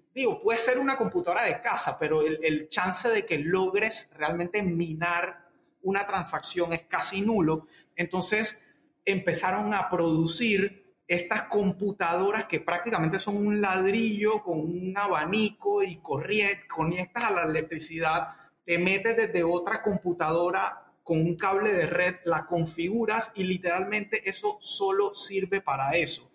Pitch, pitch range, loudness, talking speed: 185 Hz, 170-210 Hz, -27 LUFS, 135 wpm